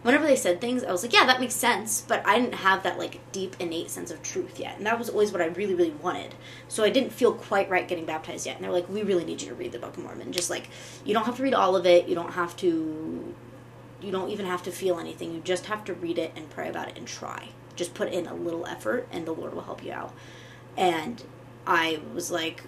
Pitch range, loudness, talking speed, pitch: 170-210 Hz, -27 LUFS, 275 wpm, 180 Hz